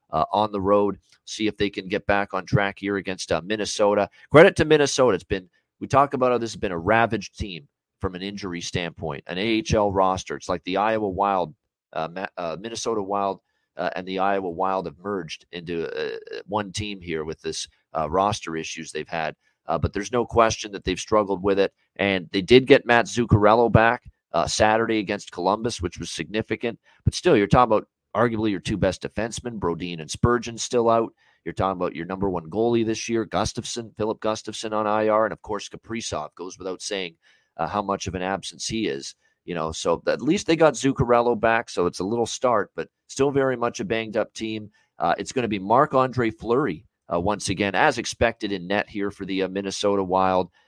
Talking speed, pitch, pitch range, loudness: 210 wpm, 105 Hz, 95-115 Hz, -23 LUFS